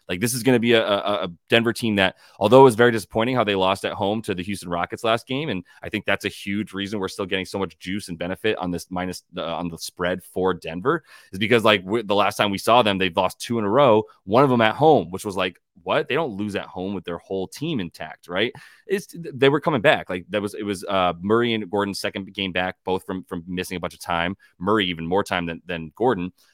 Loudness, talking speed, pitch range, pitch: -22 LUFS, 270 wpm, 90-110 Hz, 100 Hz